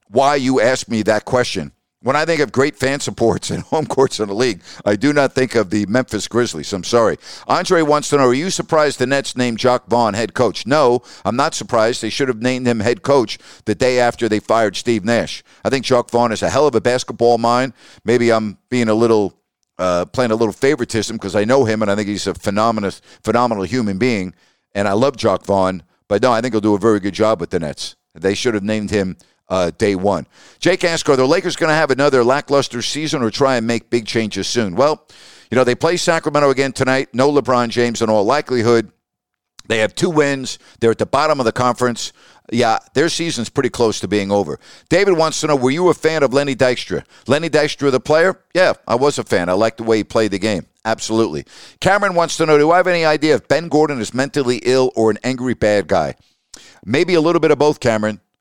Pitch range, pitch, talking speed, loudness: 110-140 Hz, 120 Hz, 235 wpm, -17 LUFS